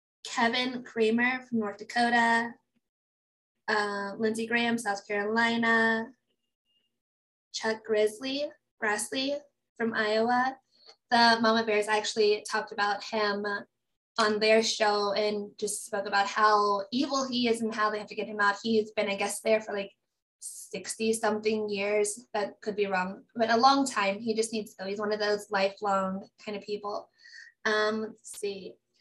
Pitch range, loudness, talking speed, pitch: 205-230 Hz, -28 LUFS, 155 wpm, 215 Hz